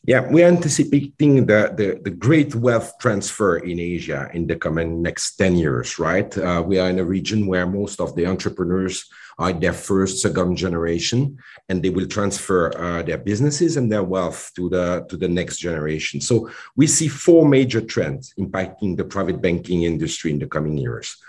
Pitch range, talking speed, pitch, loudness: 85-120 Hz, 185 wpm, 95 Hz, -20 LUFS